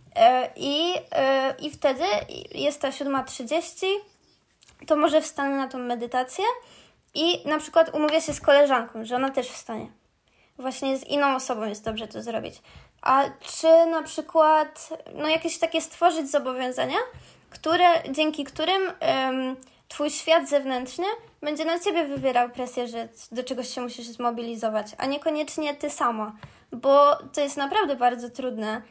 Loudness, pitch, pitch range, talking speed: -24 LUFS, 285 Hz, 255-320 Hz, 145 wpm